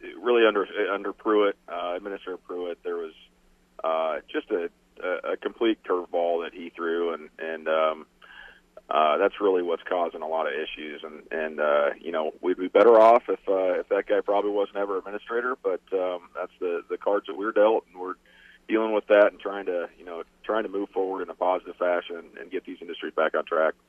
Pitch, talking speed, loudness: 120 Hz, 205 wpm, -26 LUFS